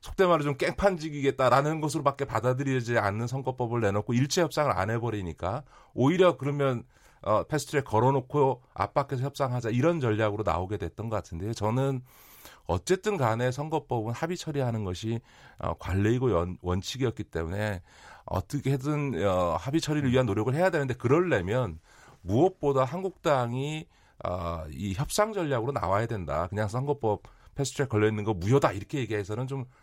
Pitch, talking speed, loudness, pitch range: 130 Hz, 370 characters per minute, -28 LUFS, 105-145 Hz